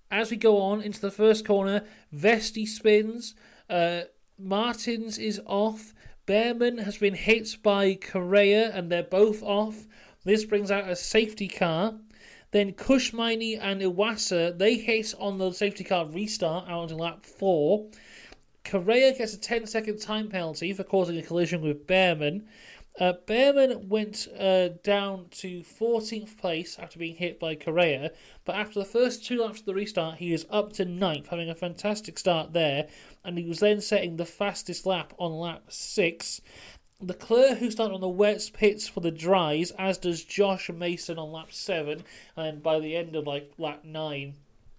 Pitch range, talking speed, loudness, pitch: 175-215 Hz, 170 wpm, -27 LUFS, 195 Hz